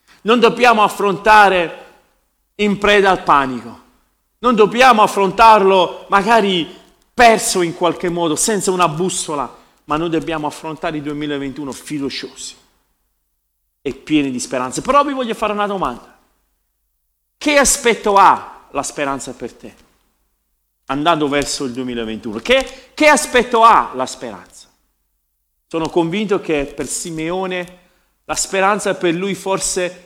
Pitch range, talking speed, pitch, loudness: 145-210 Hz, 125 wpm, 180 Hz, -15 LUFS